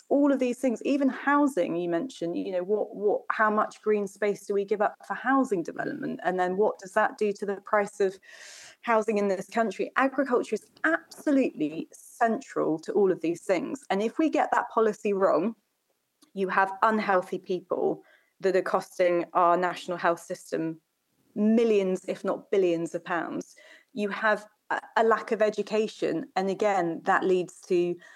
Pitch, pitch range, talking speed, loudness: 205 Hz, 185-230 Hz, 175 wpm, -27 LUFS